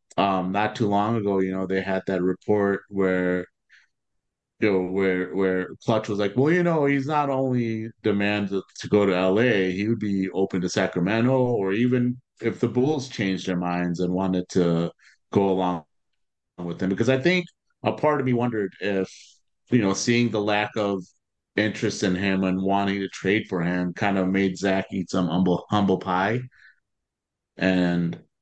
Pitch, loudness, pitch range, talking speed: 95 Hz, -24 LUFS, 95-110 Hz, 180 wpm